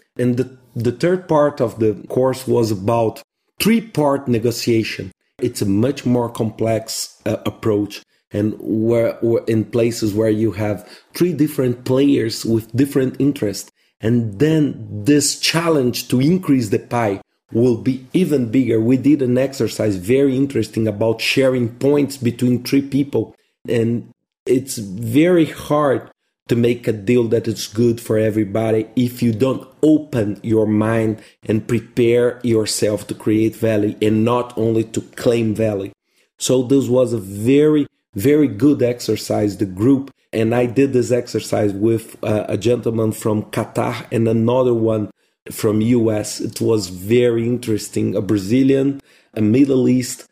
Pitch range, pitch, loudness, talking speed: 110-130 Hz, 120 Hz, -18 LUFS, 145 wpm